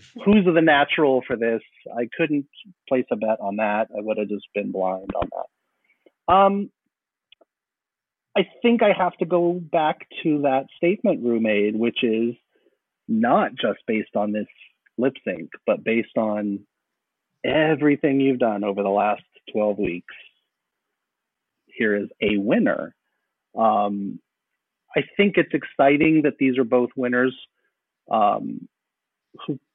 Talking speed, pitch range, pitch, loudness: 140 wpm, 105-160 Hz, 125 Hz, -22 LUFS